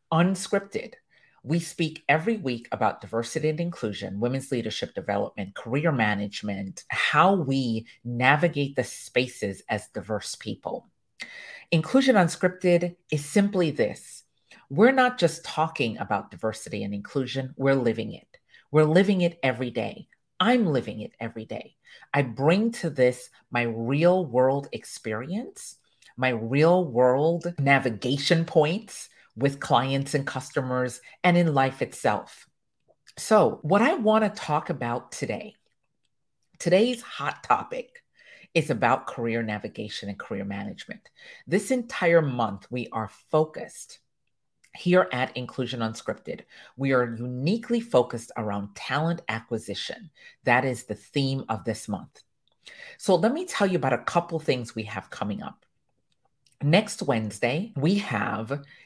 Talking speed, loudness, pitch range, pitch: 130 wpm, -26 LUFS, 120-175 Hz, 135 Hz